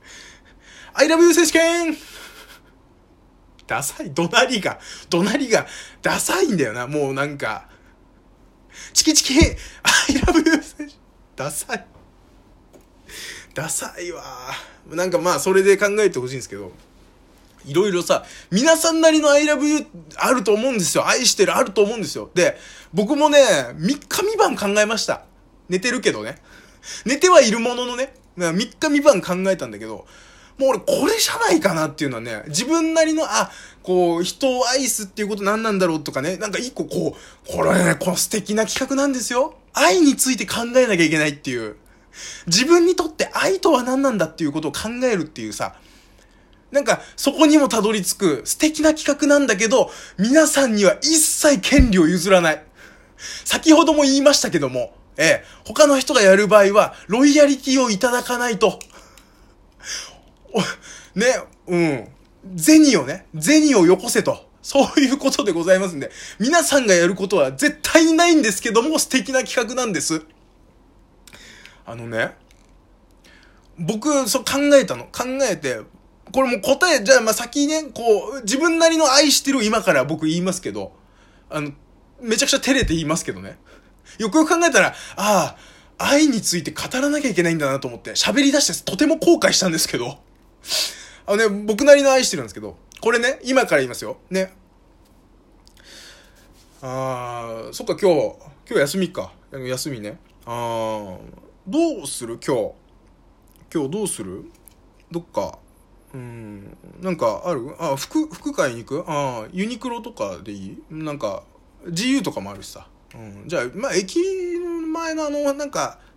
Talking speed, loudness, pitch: 315 characters per minute, -18 LUFS, 225 Hz